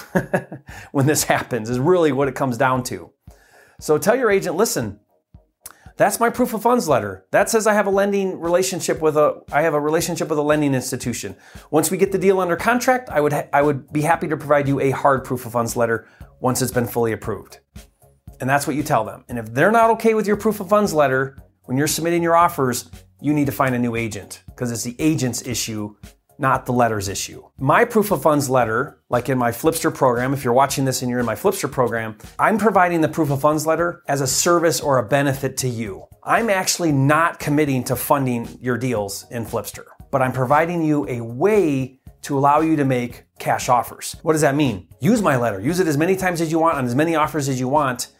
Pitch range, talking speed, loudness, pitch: 120-165 Hz, 230 wpm, -19 LUFS, 140 Hz